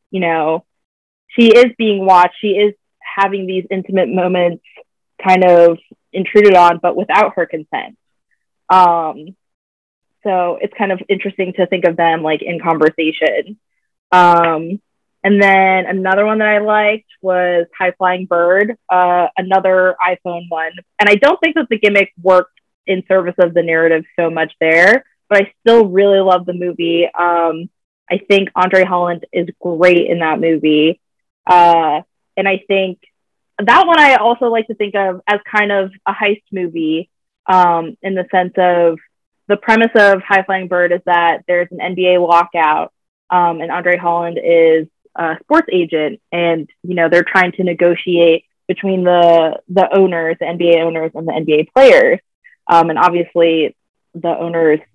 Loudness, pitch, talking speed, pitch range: -13 LUFS, 180 Hz, 160 wpm, 170-195 Hz